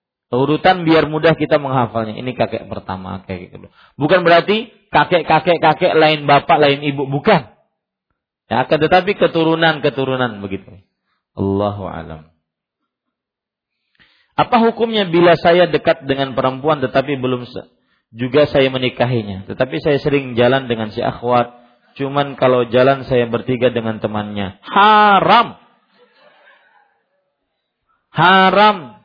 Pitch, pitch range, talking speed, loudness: 135 Hz, 120-160 Hz, 110 wpm, -15 LUFS